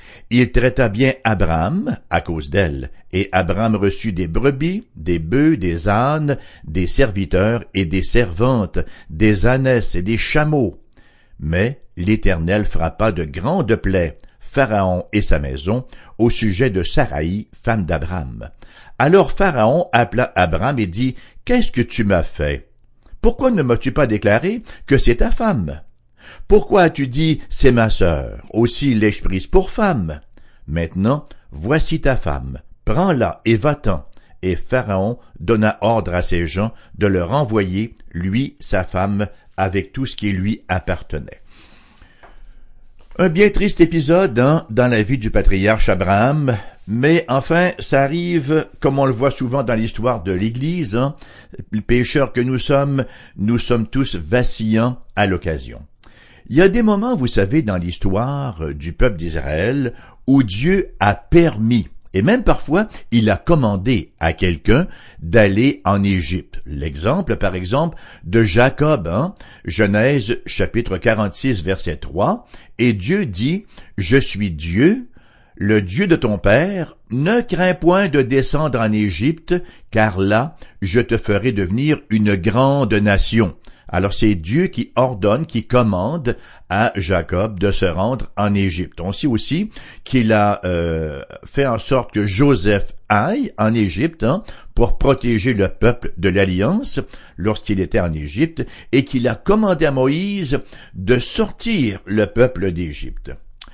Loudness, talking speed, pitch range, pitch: -18 LUFS, 145 wpm, 95-135 Hz, 110 Hz